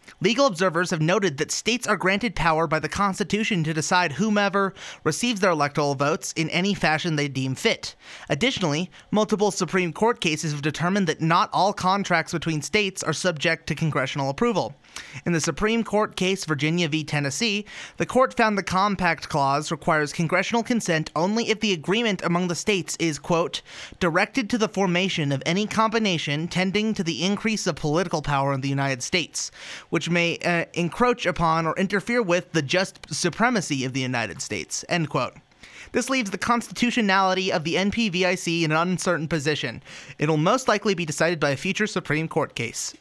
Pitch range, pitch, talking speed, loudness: 160-205 Hz, 175 Hz, 175 wpm, -23 LUFS